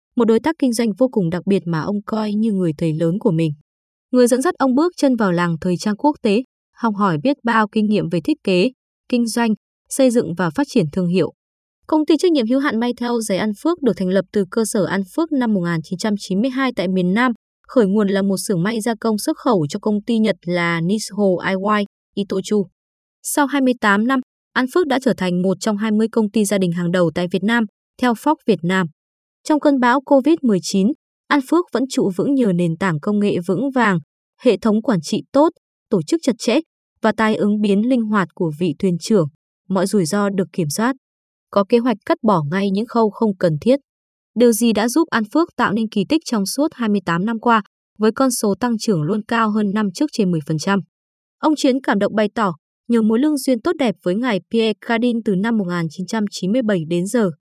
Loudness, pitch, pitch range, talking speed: -18 LUFS, 215 Hz, 195-245 Hz, 225 wpm